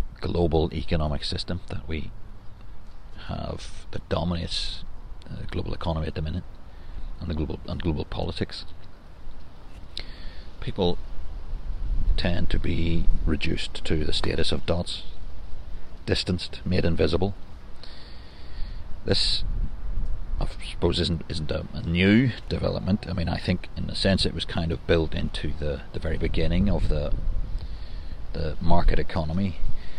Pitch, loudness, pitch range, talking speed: 85 Hz, -28 LUFS, 80-95 Hz, 130 wpm